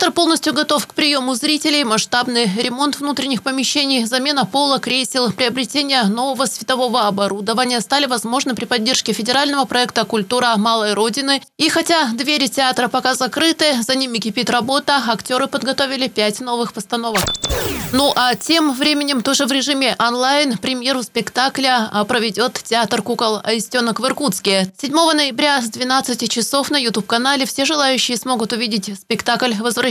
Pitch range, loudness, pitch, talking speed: 230-275 Hz, -16 LUFS, 255 Hz, 140 wpm